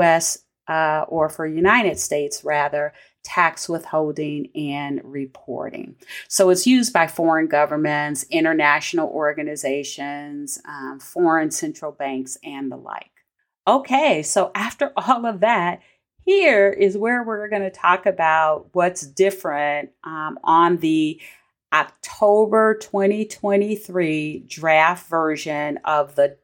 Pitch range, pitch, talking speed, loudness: 150-195 Hz, 160 Hz, 115 wpm, -20 LUFS